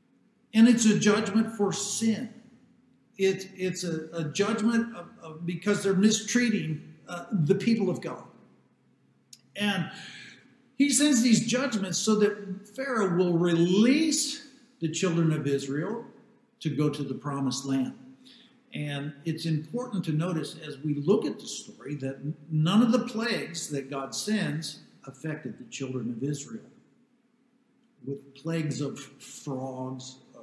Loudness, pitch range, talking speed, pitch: -28 LUFS, 150-230 Hz, 135 wpm, 190 Hz